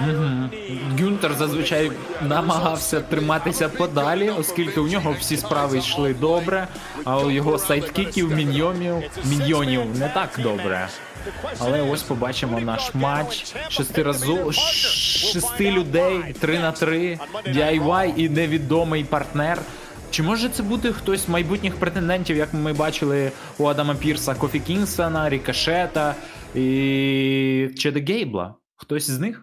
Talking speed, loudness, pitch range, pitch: 120 wpm, -22 LUFS, 140-170 Hz, 155 Hz